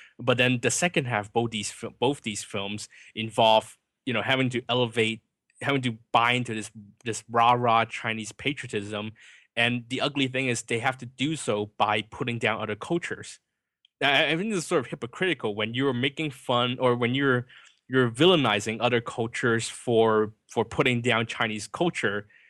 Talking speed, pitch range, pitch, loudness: 175 wpm, 110-130 Hz, 120 Hz, -26 LUFS